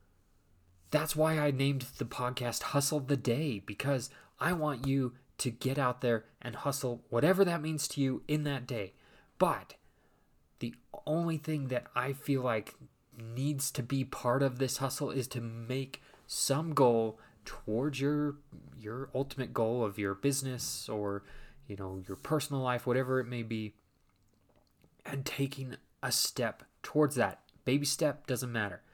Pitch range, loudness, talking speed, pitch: 120-145 Hz, -33 LUFS, 155 wpm, 130 Hz